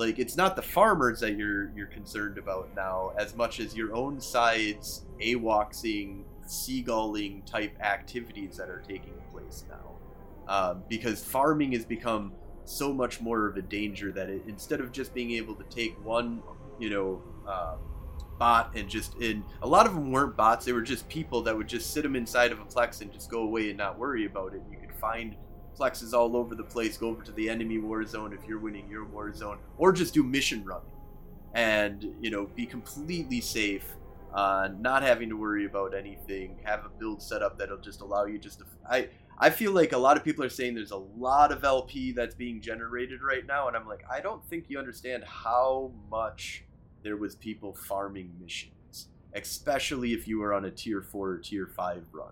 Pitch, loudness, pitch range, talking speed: 110 Hz, -30 LUFS, 100-120 Hz, 205 wpm